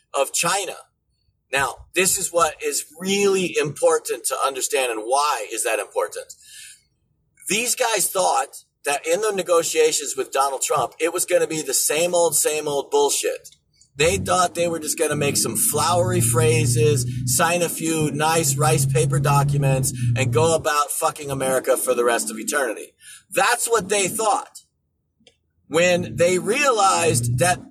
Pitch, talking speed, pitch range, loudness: 165 Hz, 160 wpm, 140-215 Hz, -20 LUFS